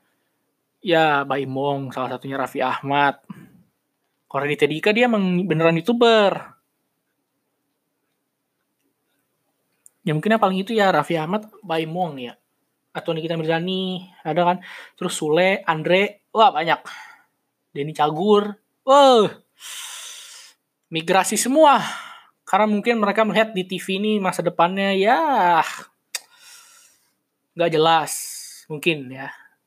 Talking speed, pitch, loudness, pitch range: 105 wpm, 180 Hz, -20 LUFS, 155-215 Hz